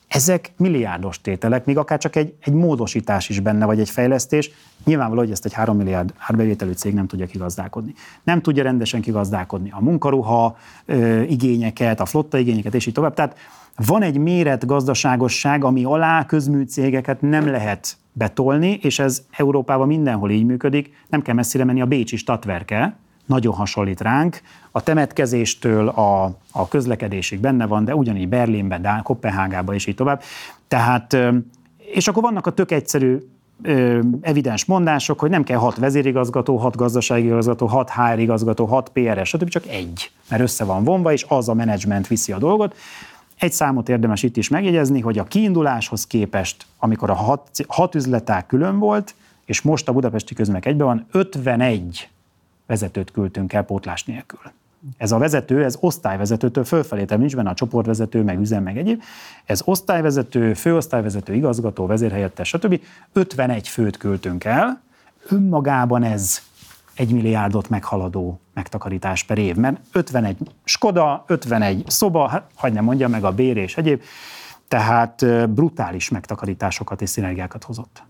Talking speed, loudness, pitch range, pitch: 155 wpm, -19 LUFS, 105-145 Hz, 120 Hz